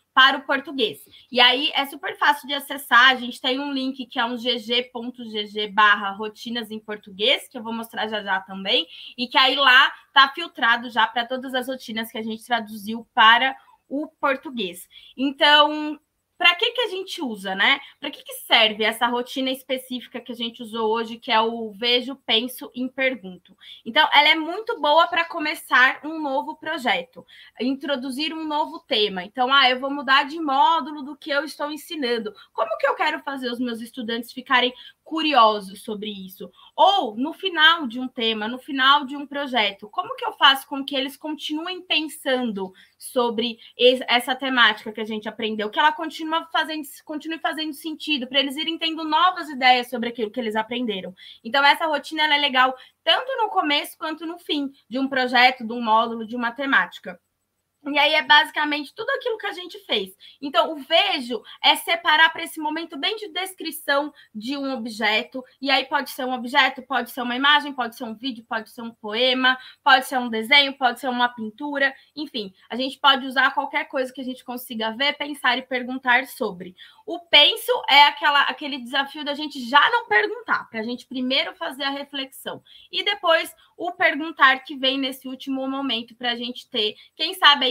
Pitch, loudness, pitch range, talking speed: 265 Hz, -21 LUFS, 240-305 Hz, 190 wpm